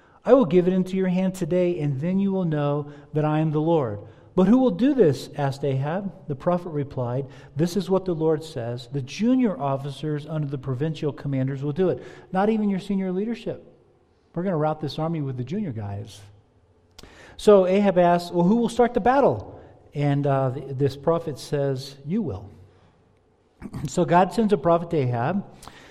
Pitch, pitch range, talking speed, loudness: 155 Hz, 135-185 Hz, 190 wpm, -23 LUFS